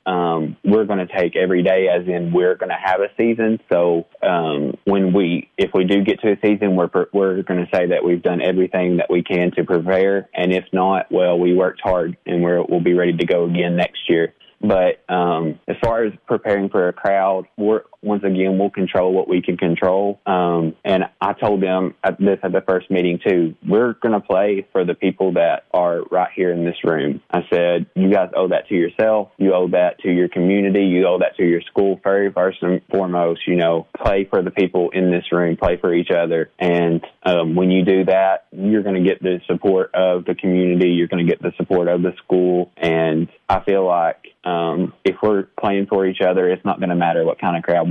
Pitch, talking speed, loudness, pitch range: 90 Hz, 225 wpm, -18 LUFS, 85-95 Hz